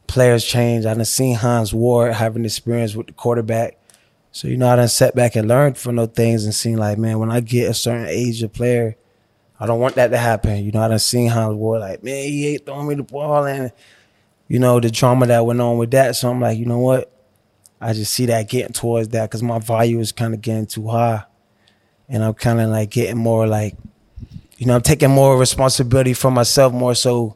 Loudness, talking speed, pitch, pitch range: -17 LUFS, 235 wpm, 120 Hz, 110-125 Hz